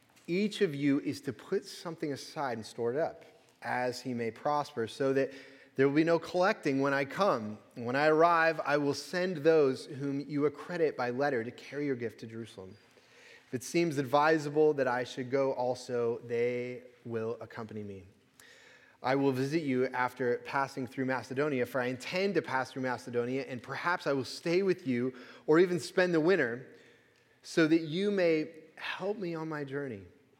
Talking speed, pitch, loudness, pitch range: 185 wpm, 140 Hz, -31 LUFS, 125-160 Hz